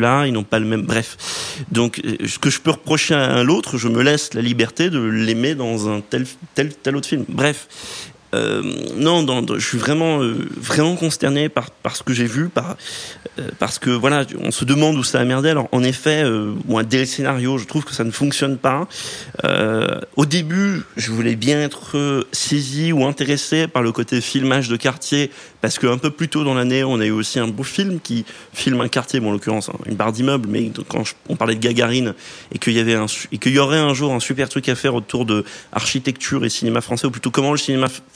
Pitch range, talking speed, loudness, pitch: 115-145 Hz, 235 wpm, -19 LUFS, 130 Hz